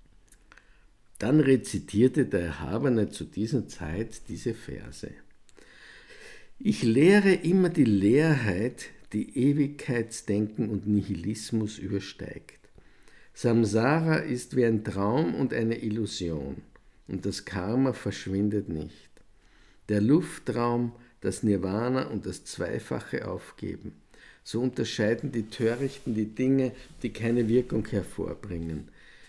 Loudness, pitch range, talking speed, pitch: -28 LUFS, 100-125 Hz, 100 wpm, 110 Hz